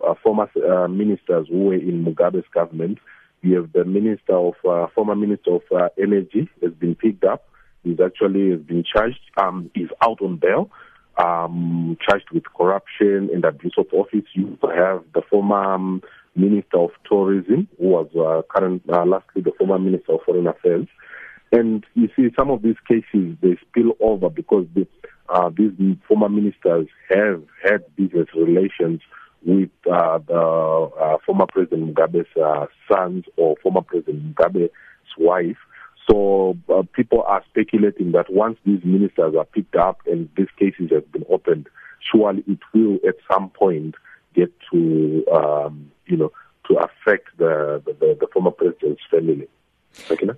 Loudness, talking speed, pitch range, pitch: -19 LUFS, 160 wpm, 85-105 Hz, 95 Hz